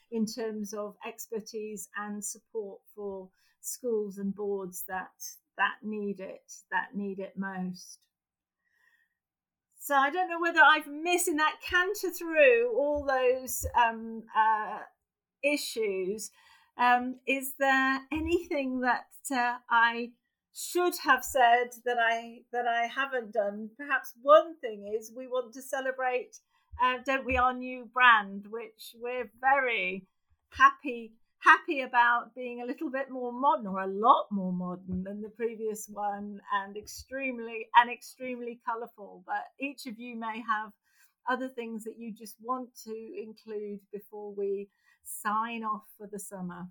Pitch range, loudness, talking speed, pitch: 210-270 Hz, -29 LUFS, 145 wpm, 235 Hz